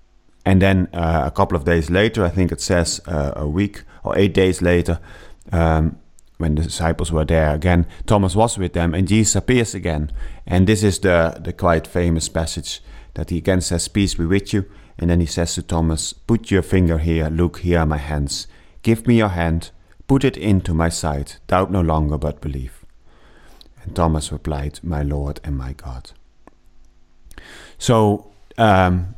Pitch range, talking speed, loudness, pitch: 80-95 Hz, 185 wpm, -19 LUFS, 85 Hz